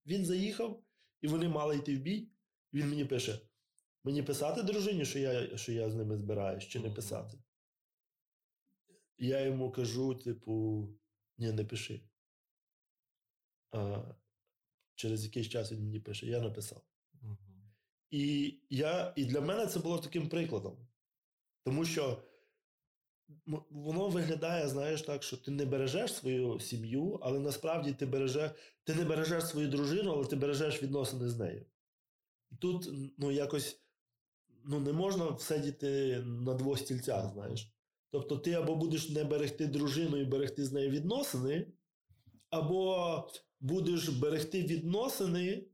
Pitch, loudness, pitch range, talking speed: 140 Hz, -36 LUFS, 120-160 Hz, 135 wpm